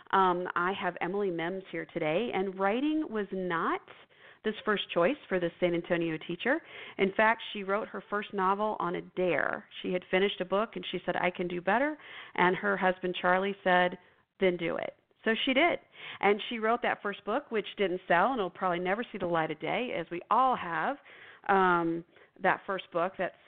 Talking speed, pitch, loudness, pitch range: 200 wpm, 185 Hz, -30 LUFS, 175-205 Hz